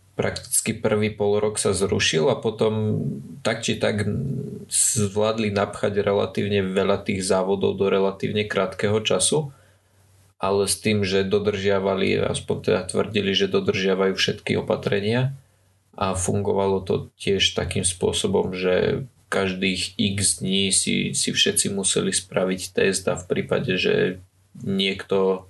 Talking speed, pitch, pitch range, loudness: 125 wpm, 100 Hz, 95-105 Hz, -22 LUFS